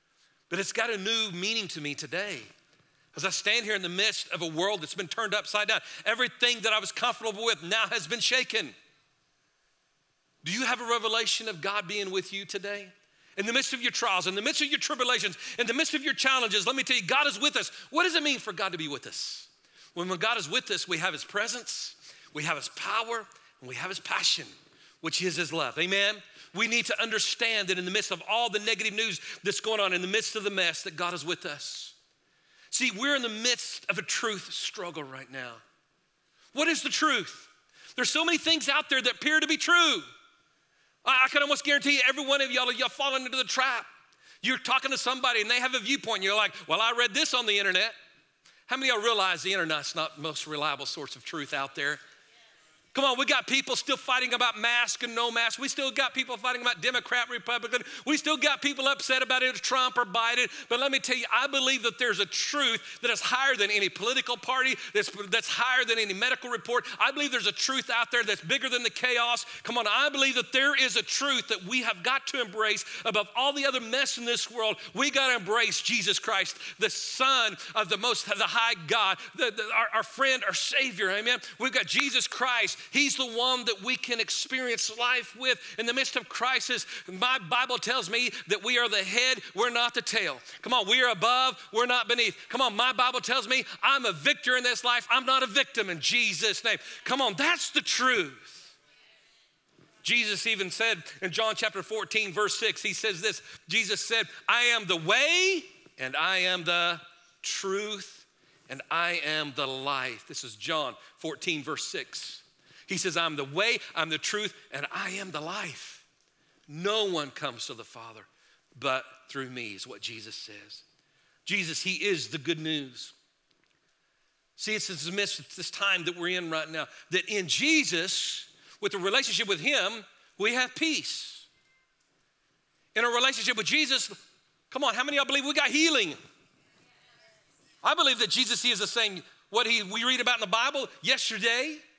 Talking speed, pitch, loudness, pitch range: 210 wpm, 230 Hz, -27 LUFS, 200-260 Hz